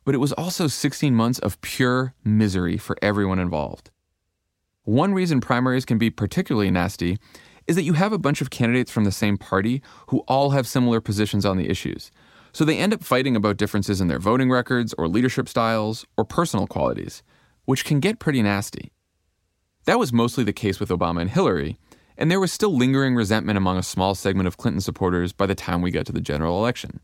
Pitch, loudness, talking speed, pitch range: 110 Hz, -22 LUFS, 205 wpm, 95-130 Hz